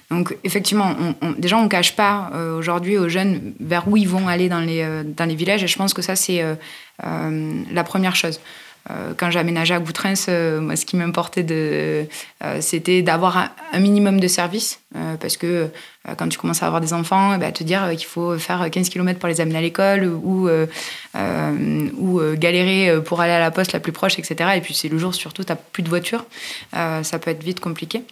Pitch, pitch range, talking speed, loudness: 175 Hz, 165-185 Hz, 230 wpm, -20 LUFS